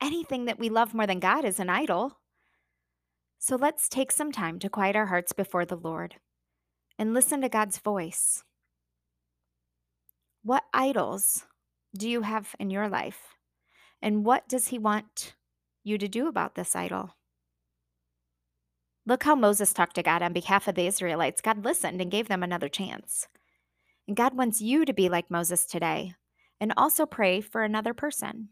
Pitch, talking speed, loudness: 190 Hz, 165 wpm, -27 LUFS